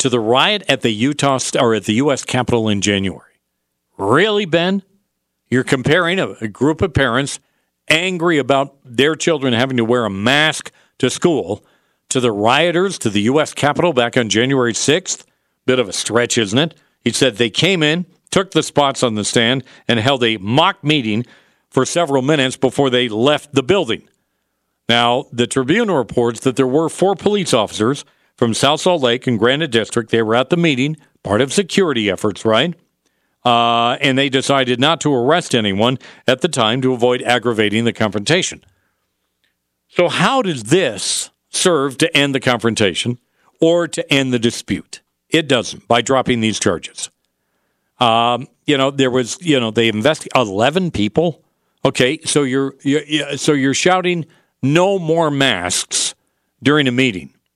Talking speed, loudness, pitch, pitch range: 170 wpm, -16 LUFS, 130 Hz, 120-155 Hz